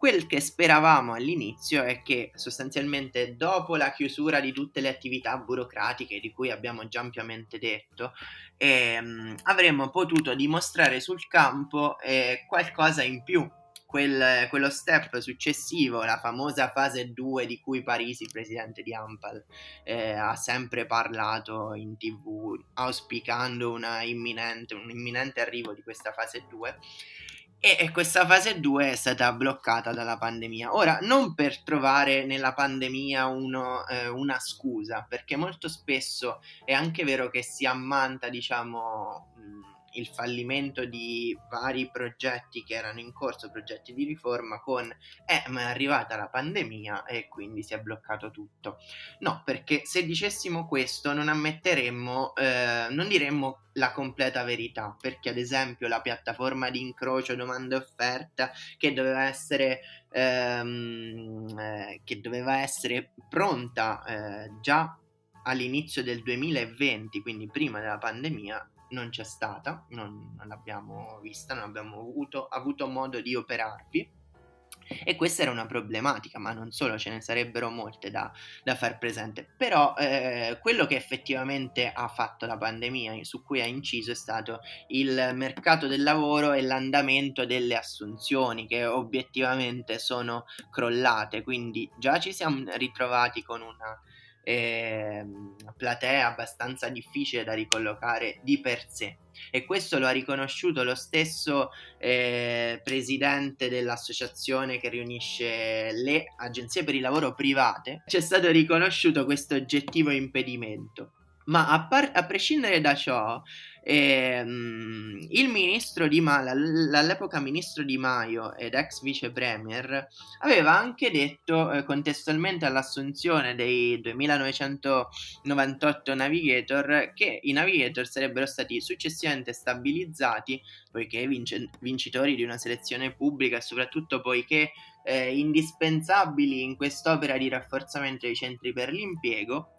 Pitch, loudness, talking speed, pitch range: 130 Hz, -27 LUFS, 130 wpm, 115-145 Hz